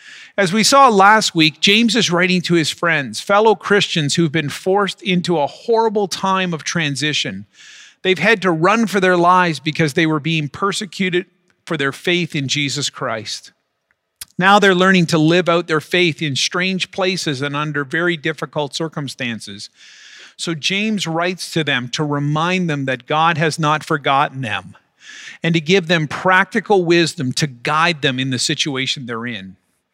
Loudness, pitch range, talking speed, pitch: -16 LUFS, 145-185 Hz, 170 wpm, 165 Hz